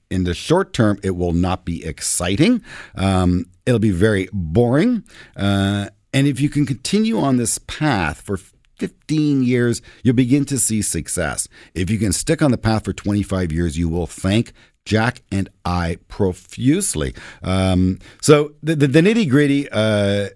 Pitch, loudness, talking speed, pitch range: 105 Hz, -19 LUFS, 165 wpm, 95-135 Hz